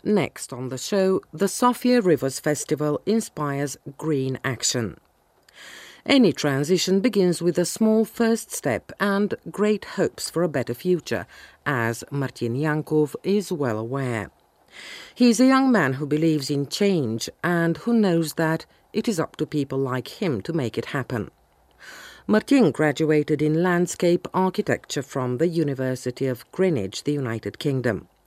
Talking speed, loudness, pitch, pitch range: 145 wpm, -23 LUFS, 155 Hz, 130-190 Hz